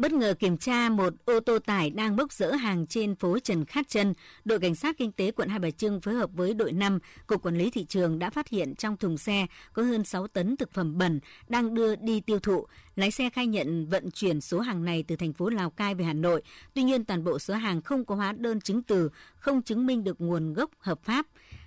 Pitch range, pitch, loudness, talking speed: 180-230 Hz, 200 Hz, -29 LUFS, 250 wpm